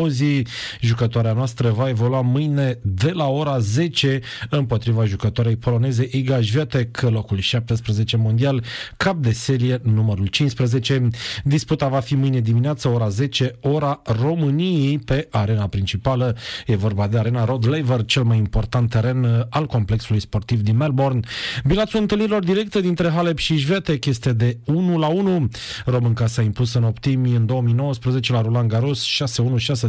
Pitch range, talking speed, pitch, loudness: 115-140 Hz, 150 wpm, 125 Hz, -20 LUFS